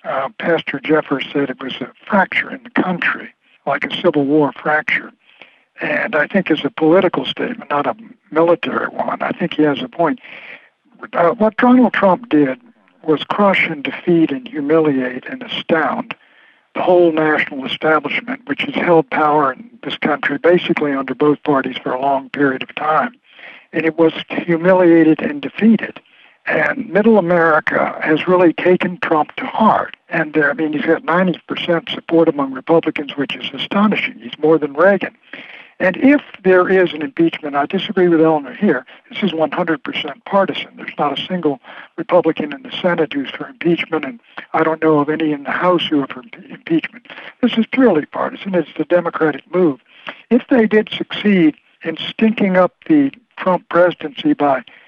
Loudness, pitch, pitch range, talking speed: -16 LUFS, 165 Hz, 150-190 Hz, 170 wpm